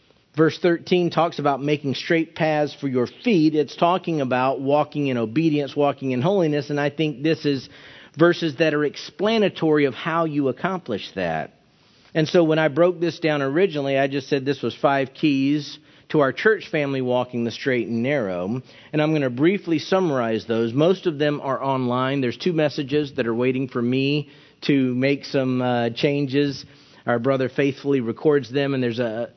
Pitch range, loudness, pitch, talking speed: 130-155 Hz, -22 LUFS, 145 Hz, 185 wpm